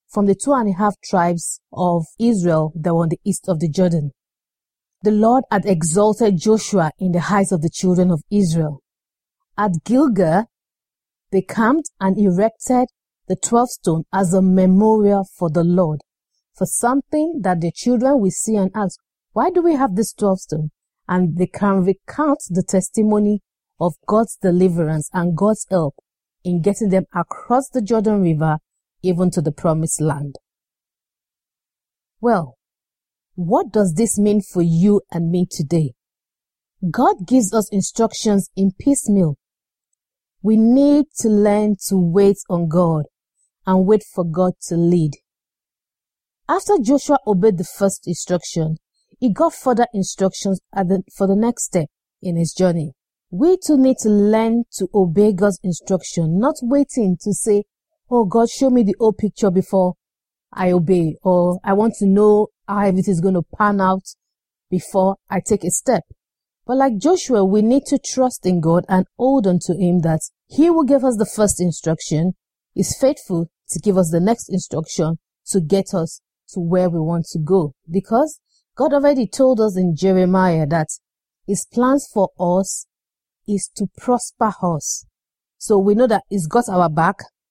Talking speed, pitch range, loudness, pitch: 165 wpm, 175-220 Hz, -18 LUFS, 195 Hz